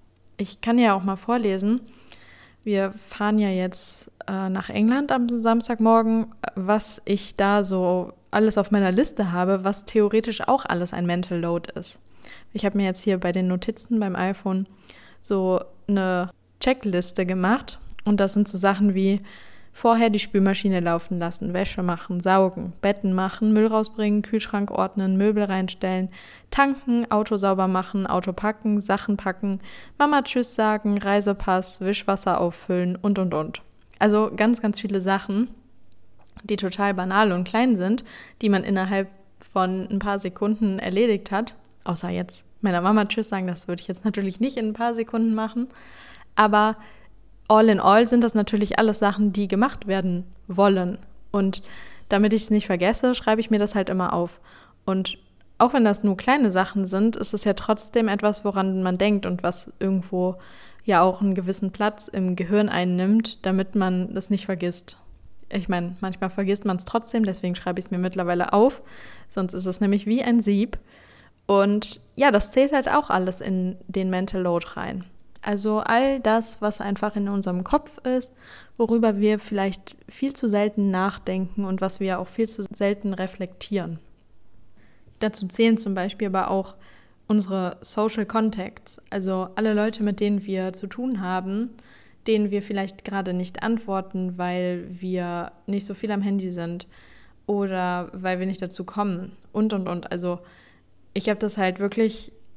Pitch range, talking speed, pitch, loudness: 185-215 Hz, 165 wpm, 200 Hz, -23 LUFS